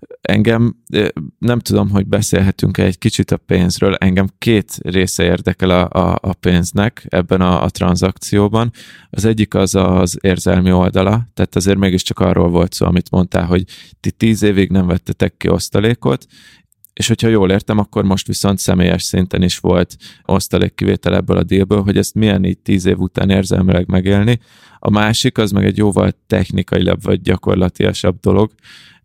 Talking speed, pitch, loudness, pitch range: 160 wpm, 95 Hz, -15 LUFS, 90-105 Hz